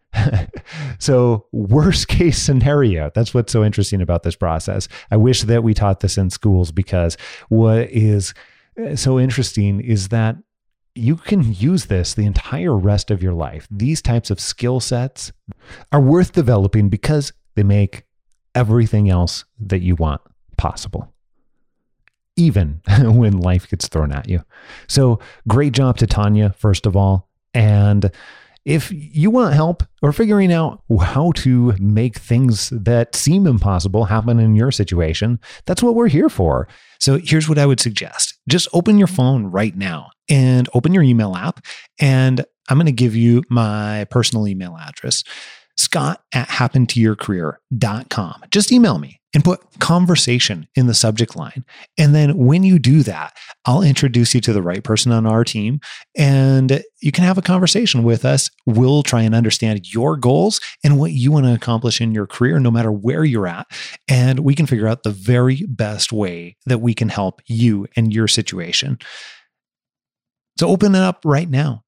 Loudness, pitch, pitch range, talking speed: -16 LUFS, 120 Hz, 105-140 Hz, 165 wpm